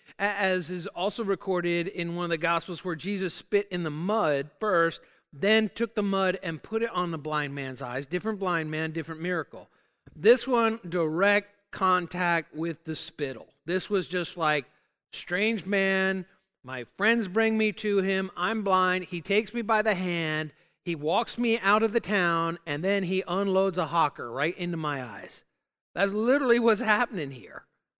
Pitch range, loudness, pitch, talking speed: 165-205 Hz, -27 LUFS, 185 Hz, 175 wpm